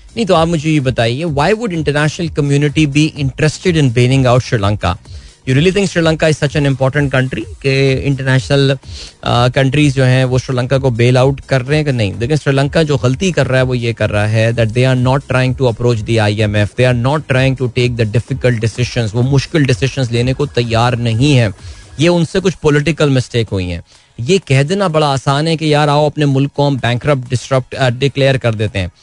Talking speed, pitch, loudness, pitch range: 220 wpm, 130 Hz, -13 LUFS, 120-150 Hz